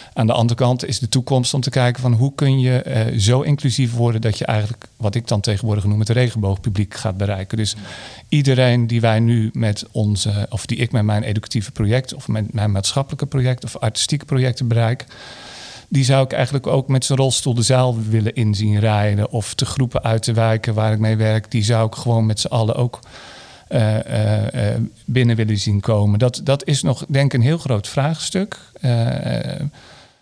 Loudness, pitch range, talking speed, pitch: -18 LUFS, 110-130 Hz, 200 wpm, 115 Hz